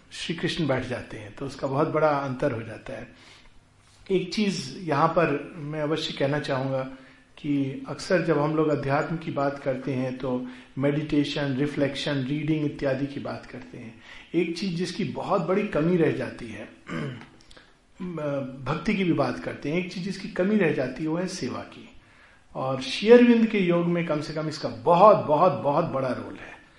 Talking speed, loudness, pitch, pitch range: 185 wpm, -25 LUFS, 150 Hz, 135-175 Hz